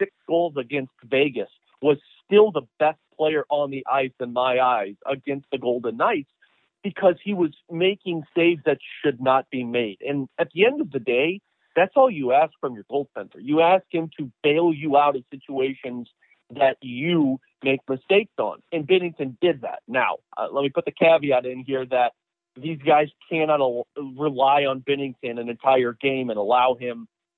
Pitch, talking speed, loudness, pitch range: 140 Hz, 185 wpm, -23 LUFS, 130-165 Hz